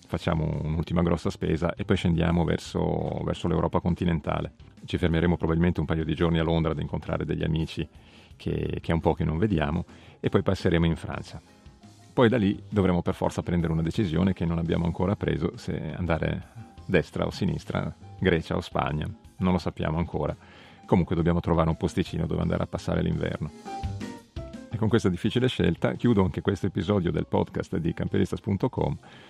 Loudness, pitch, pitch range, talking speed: -27 LUFS, 85 Hz, 85-100 Hz, 175 wpm